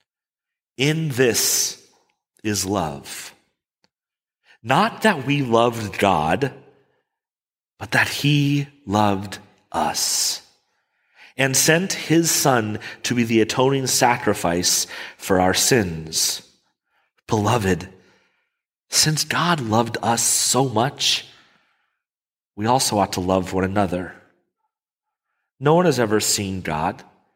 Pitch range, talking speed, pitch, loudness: 100-145 Hz, 100 wpm, 115 Hz, -20 LUFS